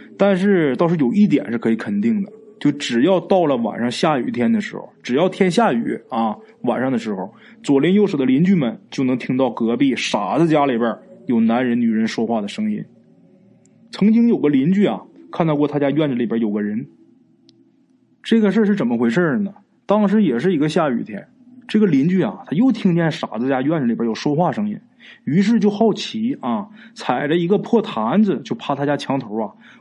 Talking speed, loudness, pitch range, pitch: 290 characters per minute, -18 LUFS, 140-215 Hz, 195 Hz